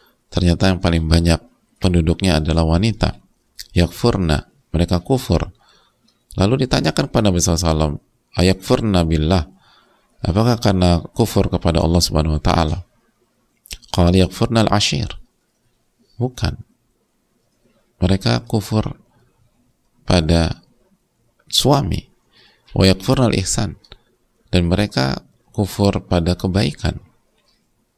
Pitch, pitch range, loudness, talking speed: 90 Hz, 85-100 Hz, -18 LUFS, 85 wpm